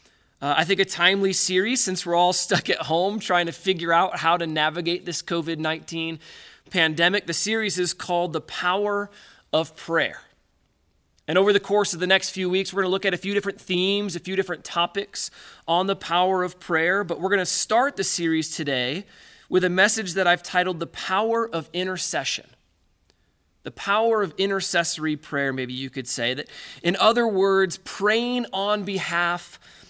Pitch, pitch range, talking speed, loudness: 180 Hz, 165-195 Hz, 185 wpm, -23 LUFS